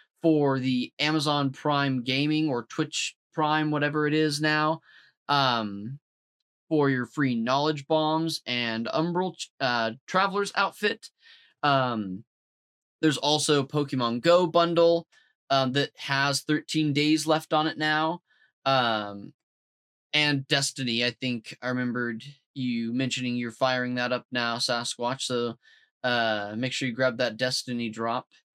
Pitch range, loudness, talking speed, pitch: 120-155 Hz, -26 LUFS, 130 wpm, 140 Hz